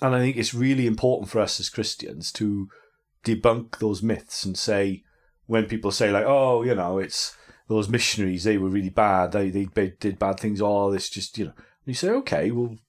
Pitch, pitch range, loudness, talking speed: 110 Hz, 100-120 Hz, -24 LUFS, 220 wpm